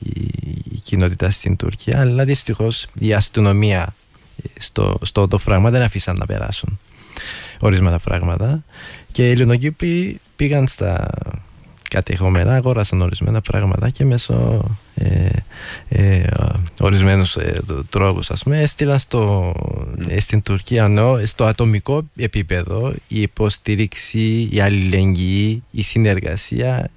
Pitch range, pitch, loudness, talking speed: 95-120 Hz, 105 Hz, -18 LUFS, 110 wpm